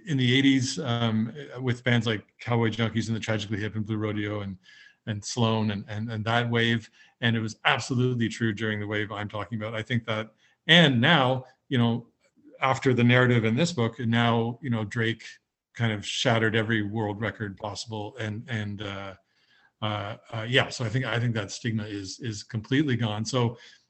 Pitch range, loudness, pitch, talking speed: 110-125 Hz, -26 LUFS, 115 Hz, 195 wpm